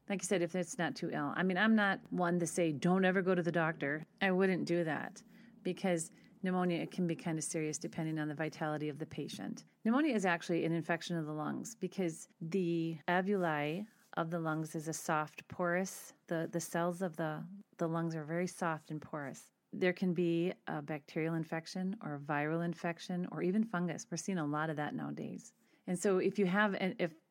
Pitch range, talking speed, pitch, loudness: 160-185 Hz, 210 wpm, 175 Hz, -36 LUFS